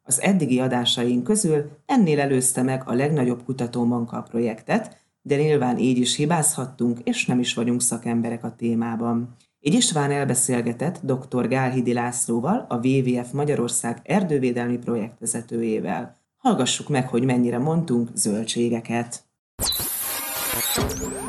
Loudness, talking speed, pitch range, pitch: -22 LUFS, 115 wpm, 120-145 Hz, 125 Hz